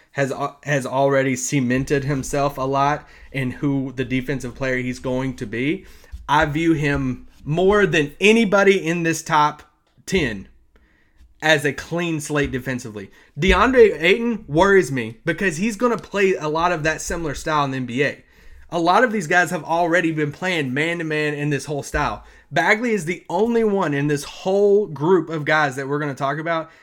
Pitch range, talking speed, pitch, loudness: 135-180 Hz, 185 wpm, 150 Hz, -20 LUFS